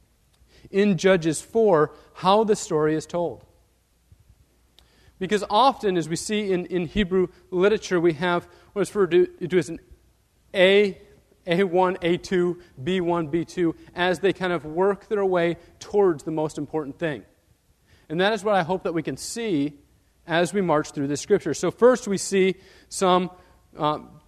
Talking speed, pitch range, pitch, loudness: 155 wpm, 160-195 Hz, 180 Hz, -23 LUFS